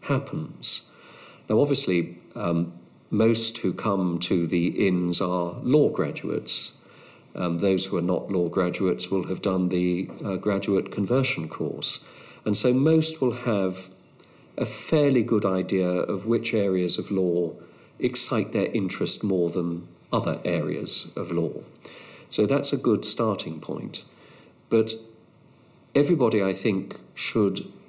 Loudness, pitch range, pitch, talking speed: -25 LUFS, 90-110 Hz, 95 Hz, 135 wpm